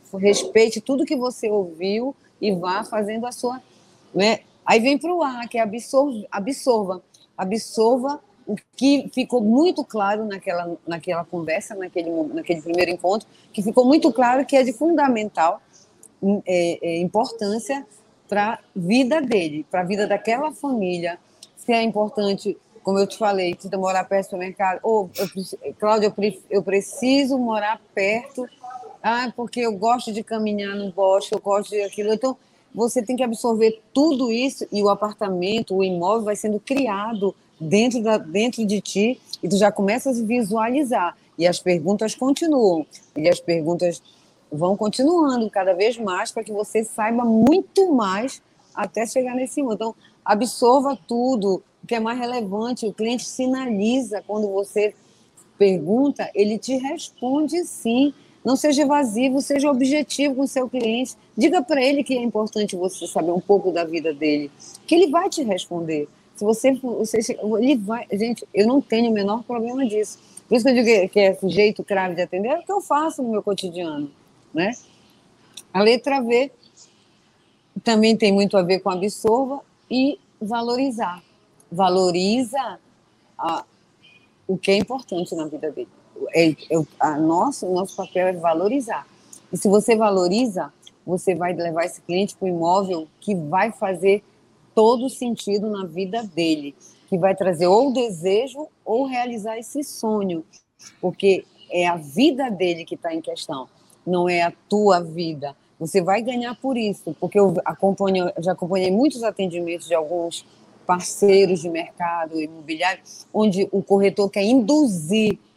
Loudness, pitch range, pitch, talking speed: -21 LUFS, 185-245 Hz, 210 Hz, 160 wpm